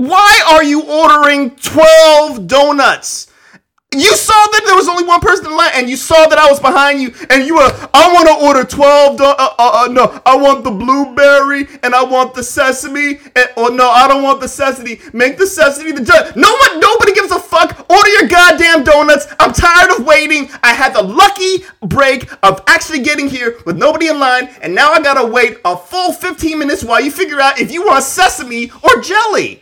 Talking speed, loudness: 210 wpm, -8 LUFS